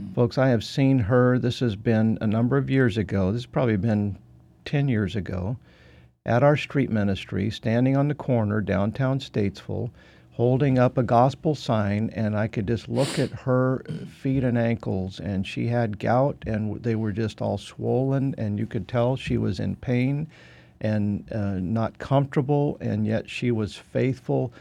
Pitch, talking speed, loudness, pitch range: 115 Hz, 175 wpm, -25 LUFS, 105-130 Hz